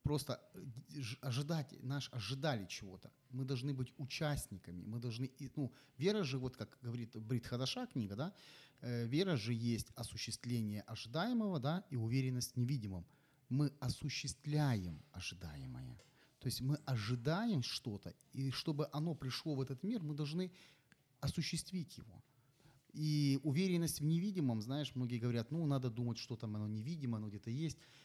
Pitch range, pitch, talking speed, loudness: 120-150 Hz, 135 Hz, 145 wpm, -41 LUFS